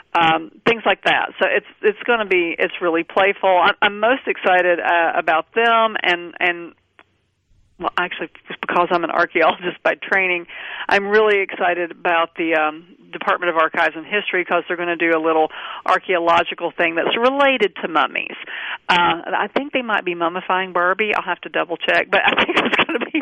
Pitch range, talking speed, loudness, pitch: 170-205 Hz, 190 wpm, -18 LUFS, 180 Hz